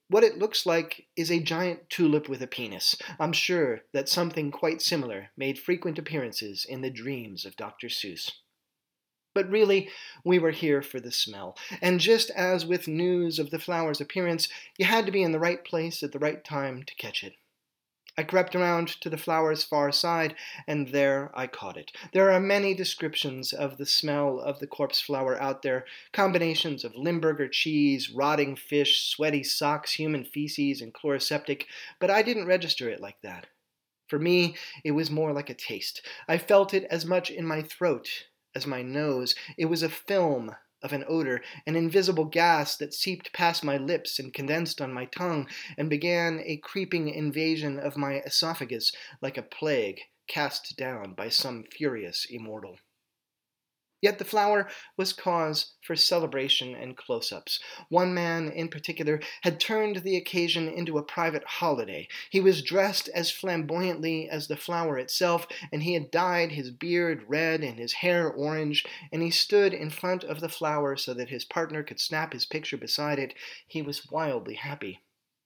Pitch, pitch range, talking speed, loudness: 160 Hz, 145-175 Hz, 175 wpm, -28 LUFS